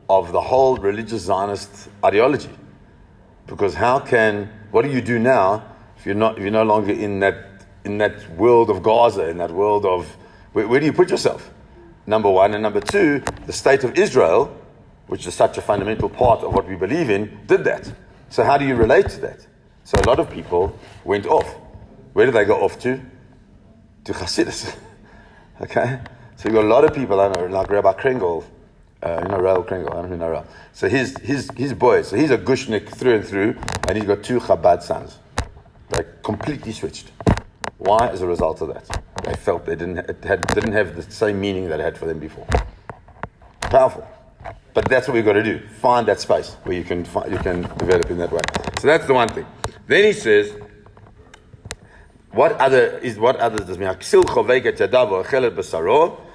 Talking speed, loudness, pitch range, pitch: 195 wpm, -19 LUFS, 100-155 Hz, 110 Hz